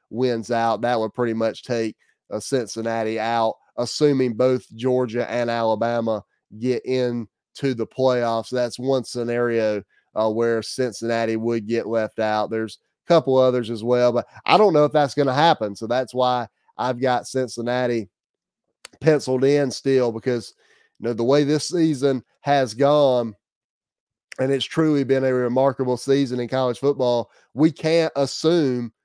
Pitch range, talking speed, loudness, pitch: 115-135 Hz, 155 wpm, -21 LUFS, 125 Hz